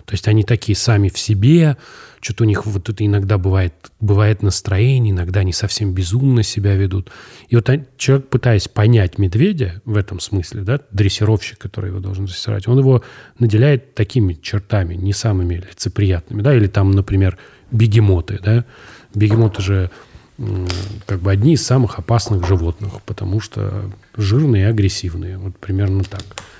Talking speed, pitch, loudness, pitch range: 155 wpm, 105 Hz, -17 LUFS, 95-115 Hz